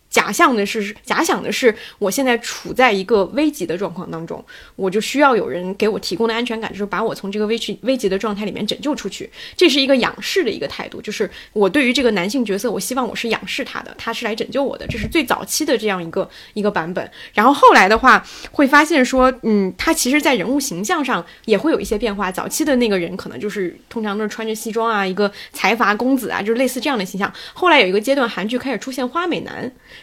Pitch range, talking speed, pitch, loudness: 205-265 Hz, 370 characters per minute, 225 Hz, -18 LUFS